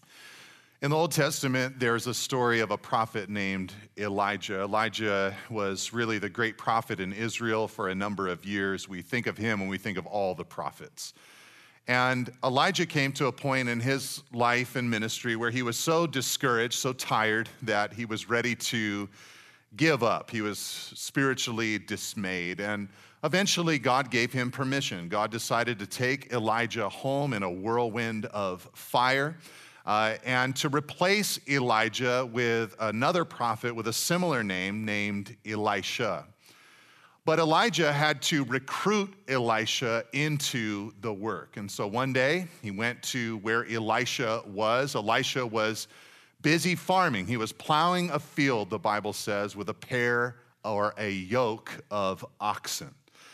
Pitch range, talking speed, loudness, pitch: 105-135 Hz, 150 wpm, -28 LUFS, 120 Hz